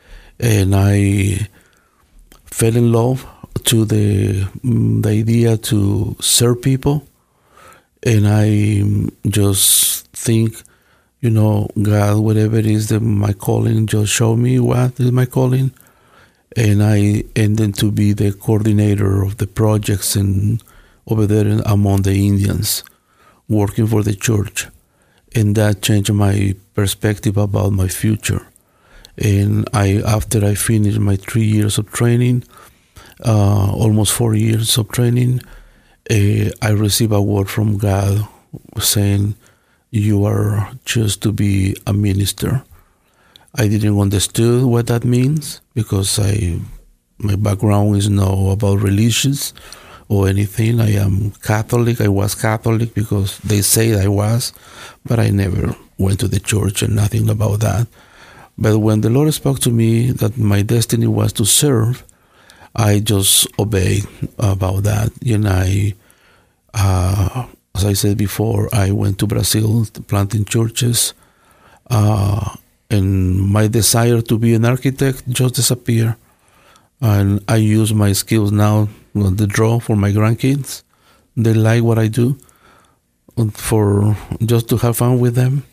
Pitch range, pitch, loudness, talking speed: 100-115 Hz, 105 Hz, -16 LUFS, 135 wpm